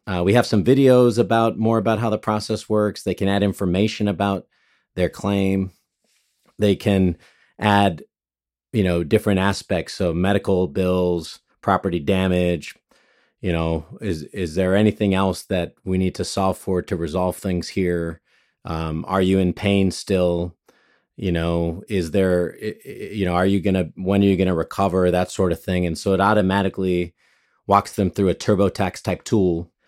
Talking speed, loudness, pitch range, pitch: 165 wpm, -21 LUFS, 90-100 Hz, 95 Hz